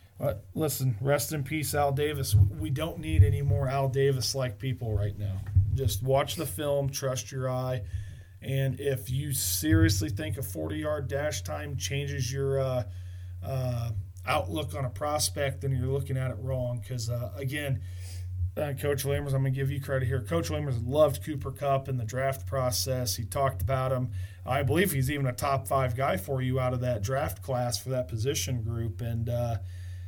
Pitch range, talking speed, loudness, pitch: 105-135 Hz, 185 wpm, -29 LUFS, 125 Hz